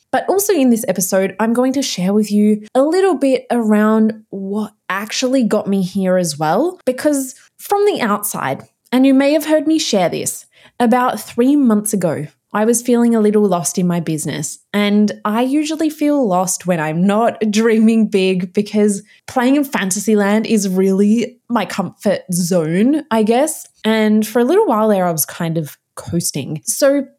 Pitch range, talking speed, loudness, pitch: 190-255 Hz, 180 wpm, -16 LUFS, 215 Hz